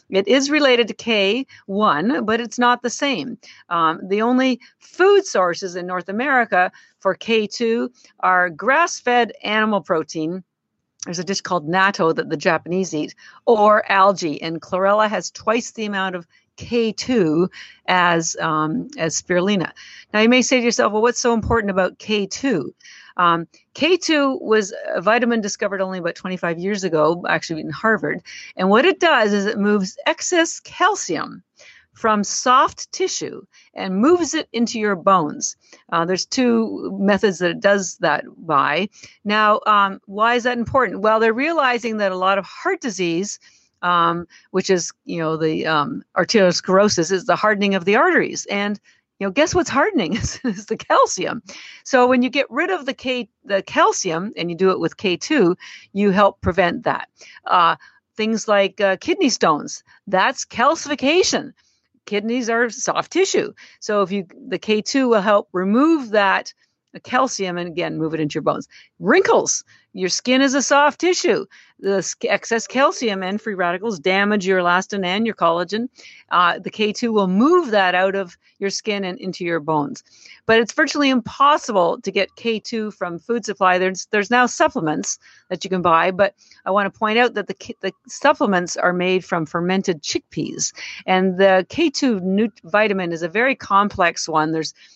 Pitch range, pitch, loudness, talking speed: 185-245 Hz, 205 Hz, -19 LUFS, 170 wpm